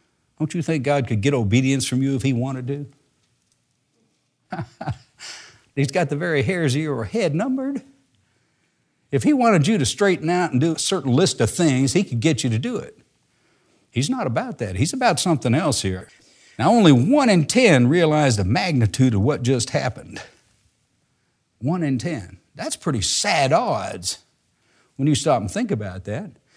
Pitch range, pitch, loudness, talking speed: 120-165 Hz, 140 Hz, -20 LUFS, 175 wpm